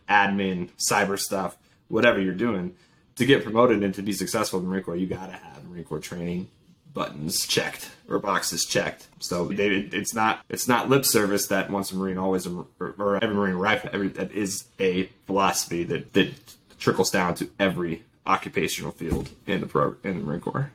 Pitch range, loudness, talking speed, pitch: 90-105 Hz, -25 LUFS, 190 wpm, 95 Hz